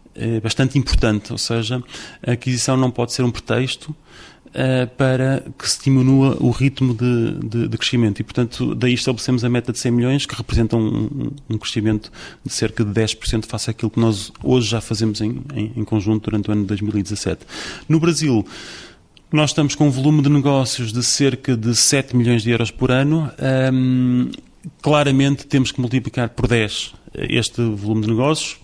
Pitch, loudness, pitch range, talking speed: 125 Hz, -19 LUFS, 115-135 Hz, 180 wpm